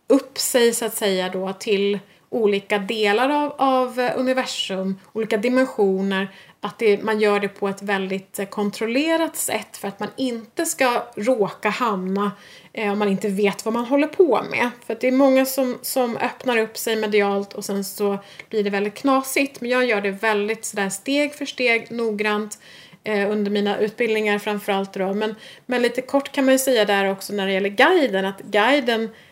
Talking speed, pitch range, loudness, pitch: 185 wpm, 200-255 Hz, -21 LUFS, 215 Hz